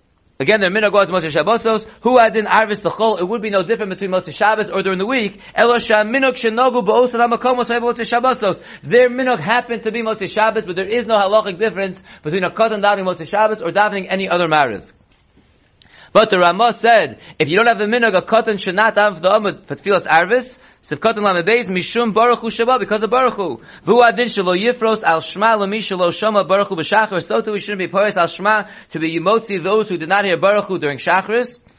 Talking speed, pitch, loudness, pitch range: 195 wpm, 215 Hz, -16 LUFS, 190-230 Hz